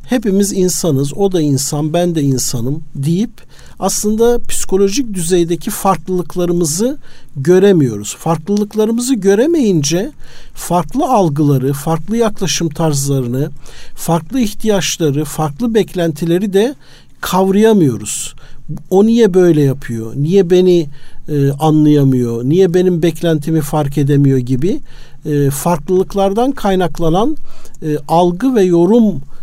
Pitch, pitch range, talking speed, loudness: 175 Hz, 150-200 Hz, 100 wpm, -13 LUFS